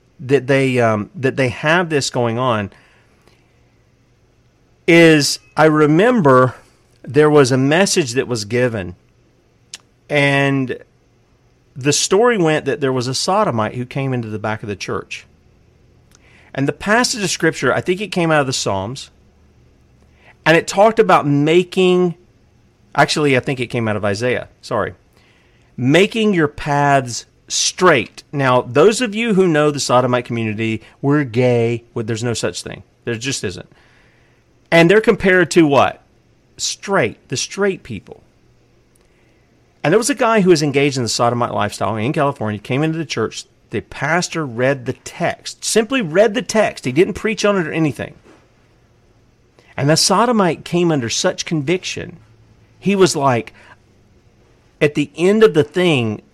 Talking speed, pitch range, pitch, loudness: 155 wpm, 120-165 Hz, 135 Hz, -16 LUFS